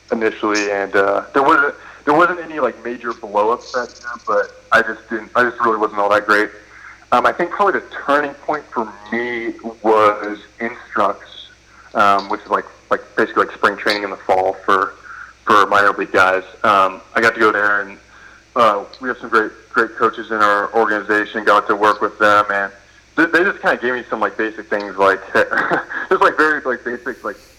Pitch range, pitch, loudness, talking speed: 105-115 Hz, 105 Hz, -17 LUFS, 200 wpm